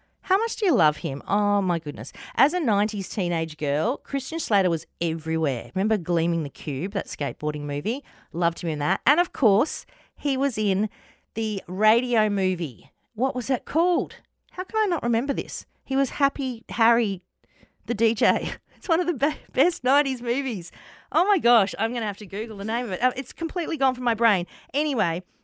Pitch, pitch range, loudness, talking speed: 220 Hz, 180-275 Hz, -24 LUFS, 190 wpm